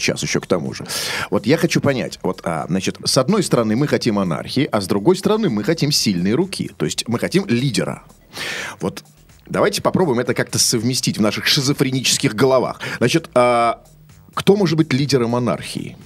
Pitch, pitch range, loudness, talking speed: 135 Hz, 120-165 Hz, -18 LUFS, 180 wpm